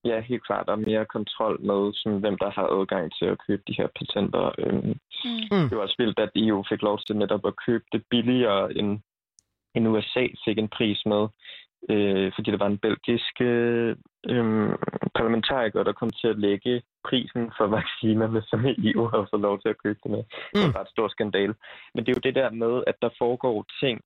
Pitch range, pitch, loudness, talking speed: 105-120 Hz, 110 Hz, -26 LUFS, 195 wpm